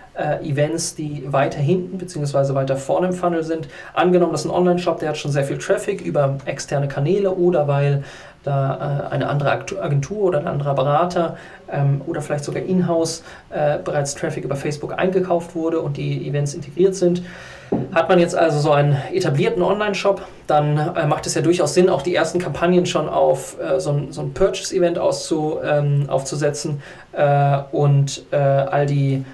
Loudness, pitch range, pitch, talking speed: -20 LUFS, 145-180 Hz, 160 Hz, 180 wpm